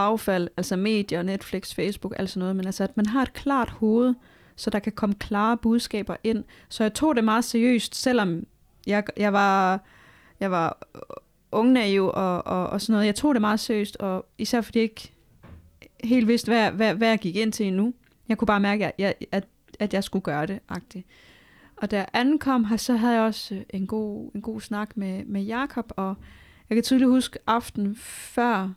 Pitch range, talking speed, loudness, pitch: 195-230 Hz, 205 wpm, -25 LUFS, 215 Hz